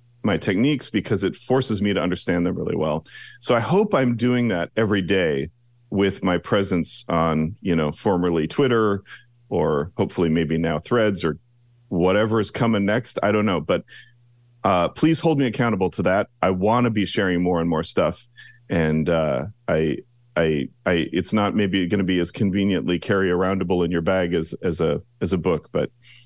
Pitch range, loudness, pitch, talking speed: 85-120 Hz, -22 LUFS, 100 Hz, 185 wpm